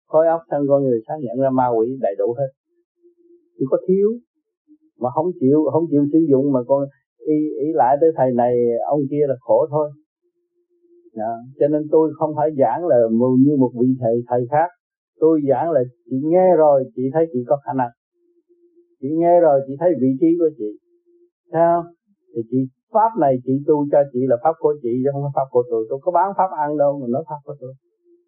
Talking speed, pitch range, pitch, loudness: 215 wpm, 130-200 Hz, 150 Hz, -18 LUFS